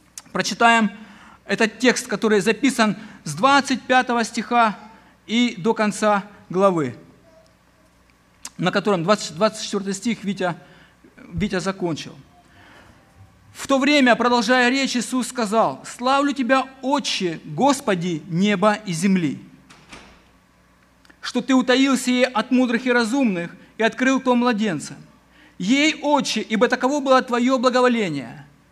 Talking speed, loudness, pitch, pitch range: 110 wpm, -20 LUFS, 225 Hz, 190-250 Hz